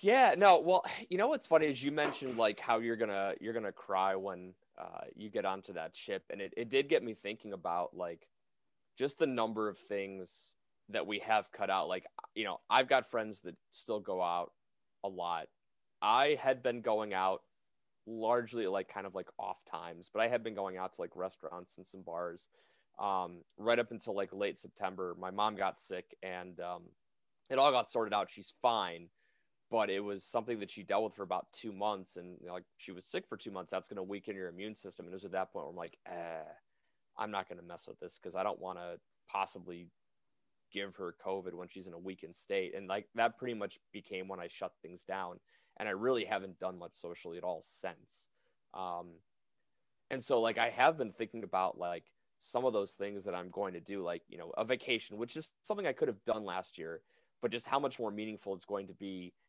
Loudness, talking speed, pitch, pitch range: -36 LUFS, 230 wpm, 100 Hz, 90-115 Hz